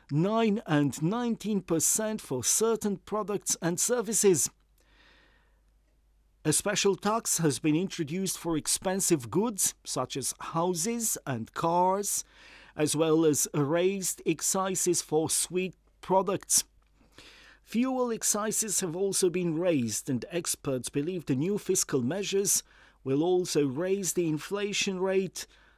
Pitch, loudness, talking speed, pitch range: 180 Hz, -28 LUFS, 115 wpm, 155-200 Hz